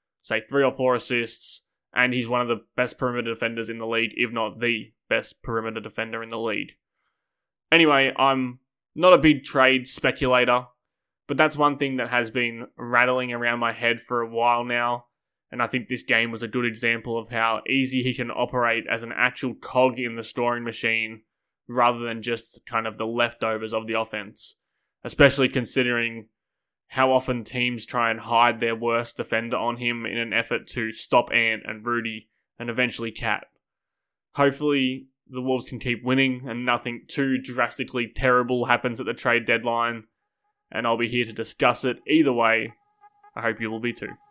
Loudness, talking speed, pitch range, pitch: -24 LUFS, 185 wpm, 115-130 Hz, 120 Hz